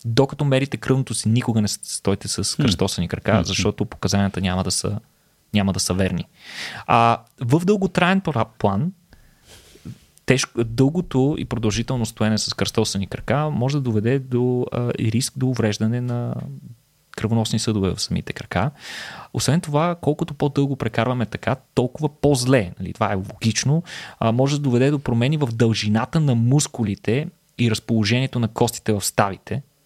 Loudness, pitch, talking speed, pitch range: -21 LUFS, 120 Hz, 150 wpm, 110-135 Hz